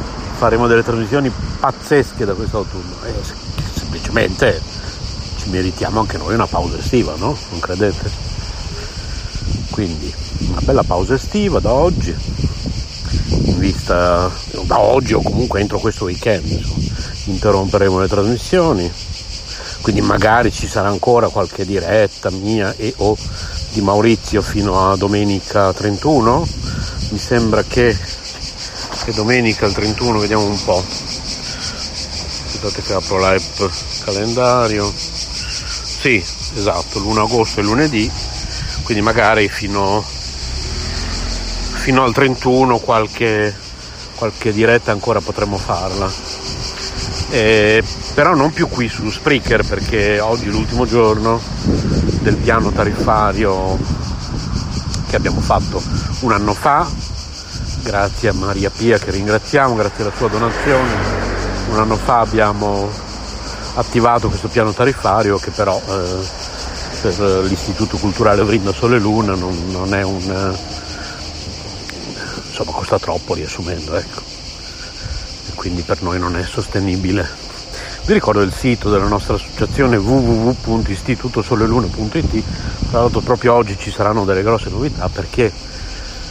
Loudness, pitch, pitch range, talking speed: -17 LUFS, 105 Hz, 90-110 Hz, 115 wpm